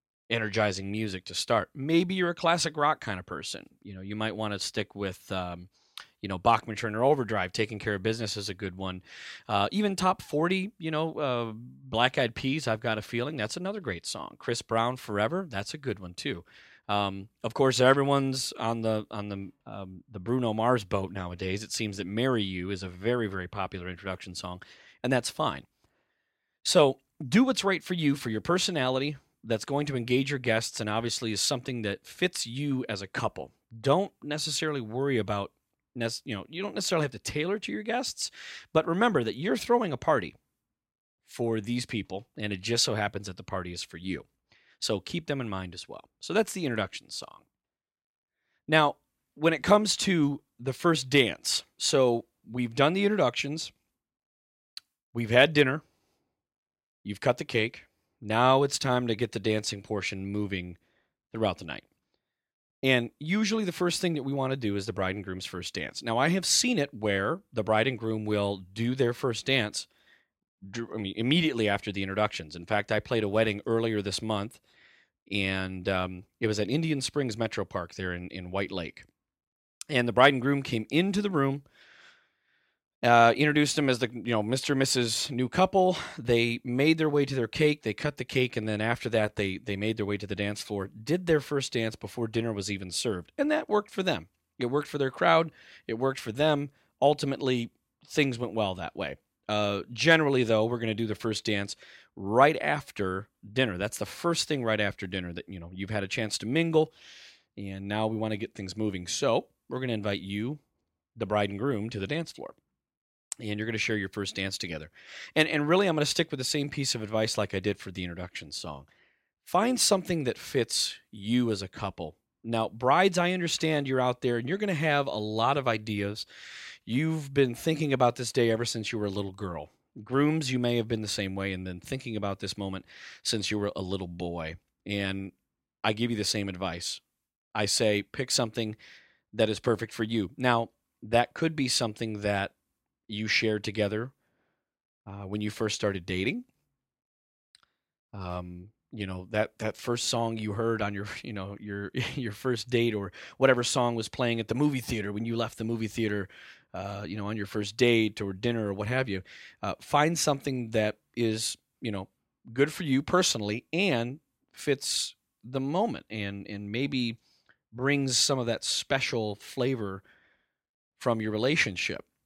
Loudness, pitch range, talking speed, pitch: -29 LUFS, 100-135 Hz, 200 wpm, 115 Hz